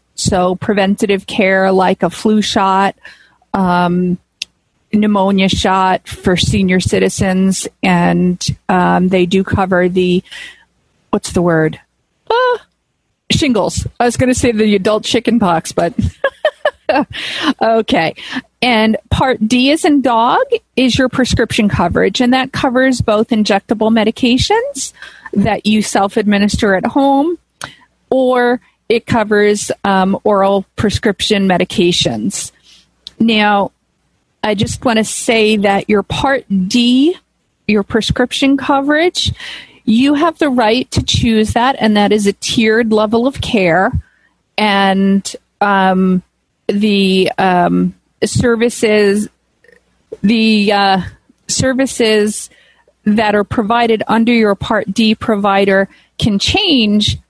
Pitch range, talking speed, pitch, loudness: 195-245 Hz, 115 wpm, 215 Hz, -13 LUFS